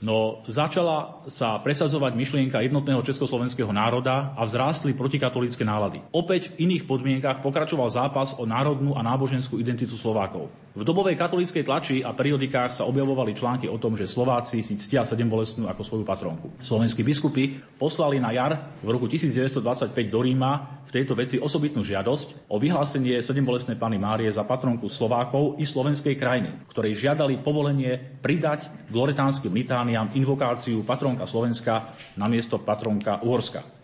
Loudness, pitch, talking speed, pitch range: -25 LUFS, 130 Hz, 145 wpm, 115-140 Hz